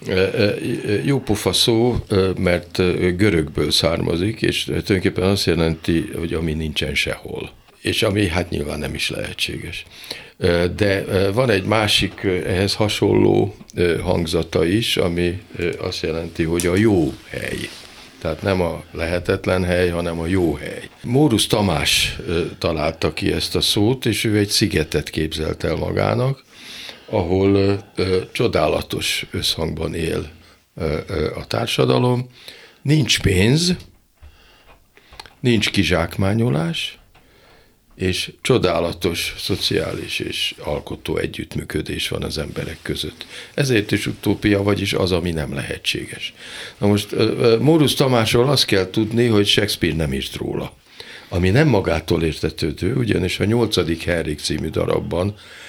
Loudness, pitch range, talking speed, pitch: -19 LUFS, 85-110 Hz, 120 wpm, 95 Hz